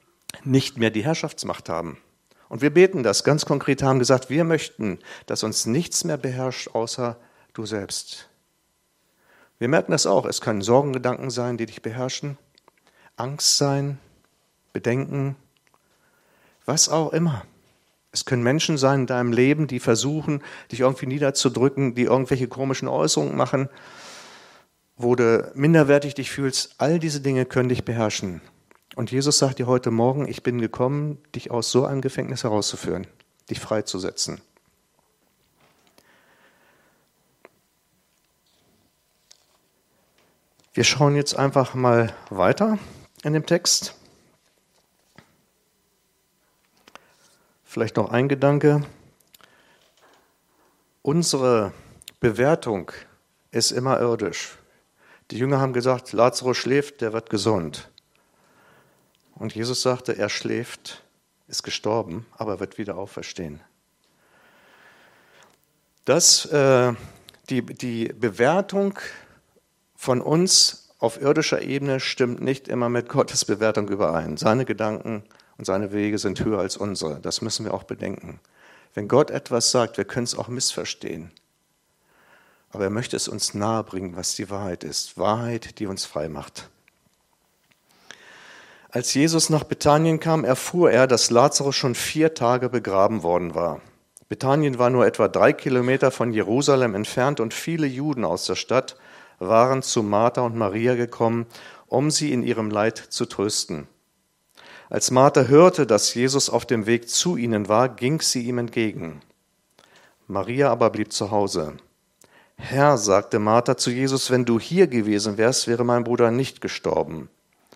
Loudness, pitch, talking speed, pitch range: -22 LUFS, 125 Hz, 130 wpm, 115-140 Hz